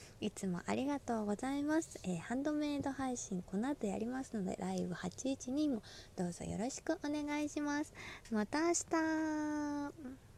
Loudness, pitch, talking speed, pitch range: -39 LUFS, 270 Hz, 295 characters per minute, 210-295 Hz